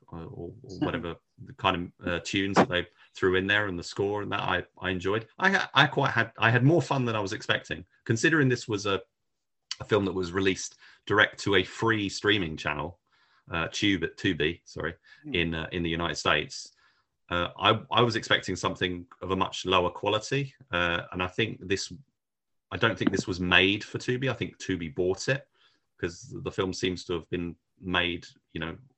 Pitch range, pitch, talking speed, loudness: 90-115 Hz, 95 Hz, 205 wpm, -27 LUFS